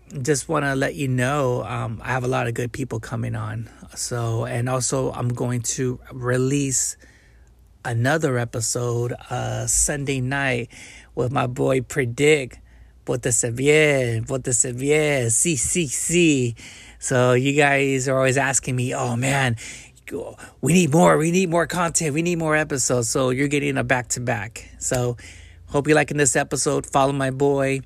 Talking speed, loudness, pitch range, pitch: 165 wpm, -21 LUFS, 120-145 Hz, 130 Hz